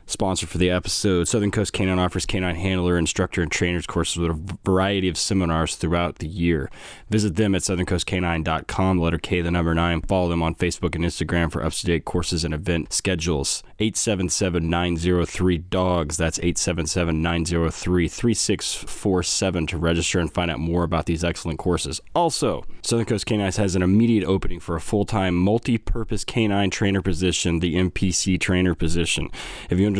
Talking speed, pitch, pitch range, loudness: 180 wpm, 90 Hz, 85-95 Hz, -22 LUFS